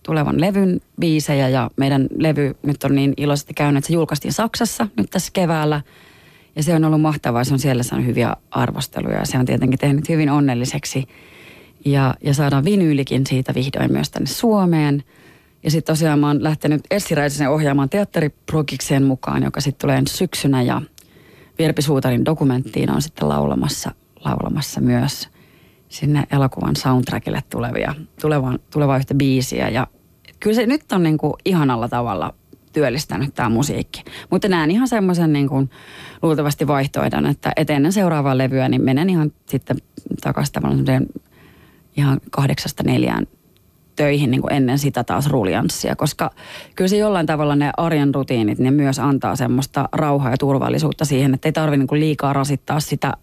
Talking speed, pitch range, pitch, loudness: 150 wpm, 135-155 Hz, 145 Hz, -19 LUFS